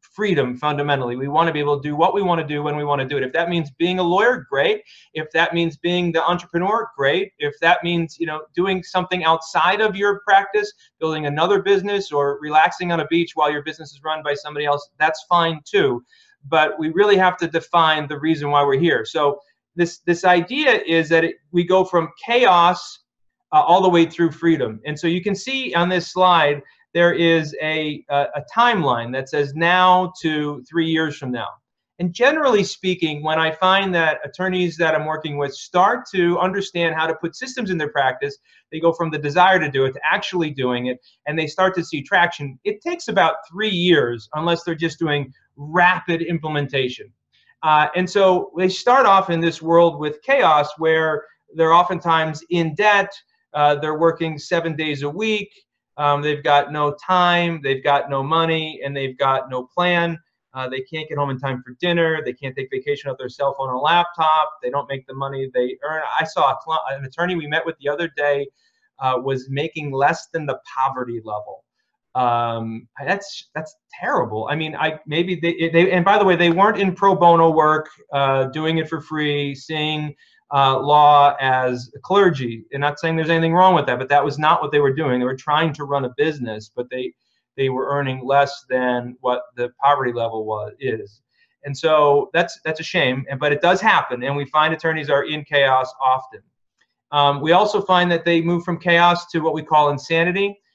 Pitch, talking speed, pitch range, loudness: 160 Hz, 205 wpm, 145-175 Hz, -19 LUFS